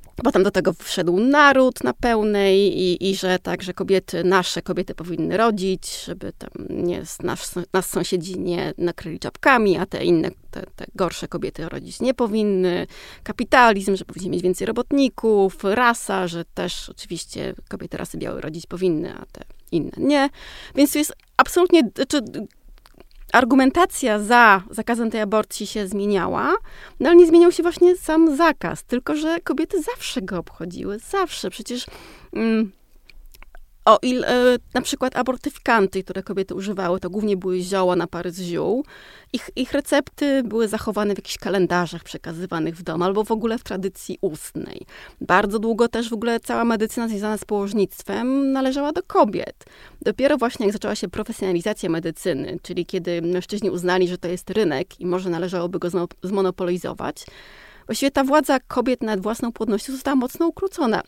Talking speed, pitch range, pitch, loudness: 160 wpm, 185-255 Hz, 210 Hz, -21 LUFS